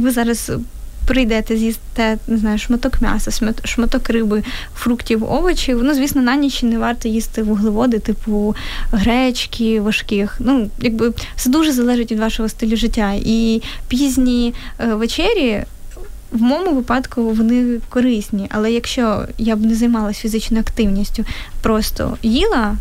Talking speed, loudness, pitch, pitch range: 135 wpm, -17 LUFS, 230 Hz, 220-245 Hz